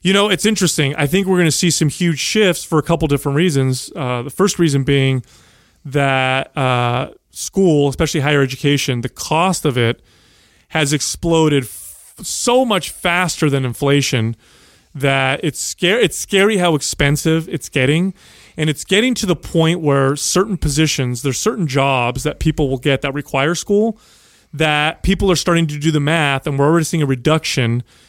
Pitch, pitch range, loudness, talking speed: 150 Hz, 135-170 Hz, -16 LUFS, 175 wpm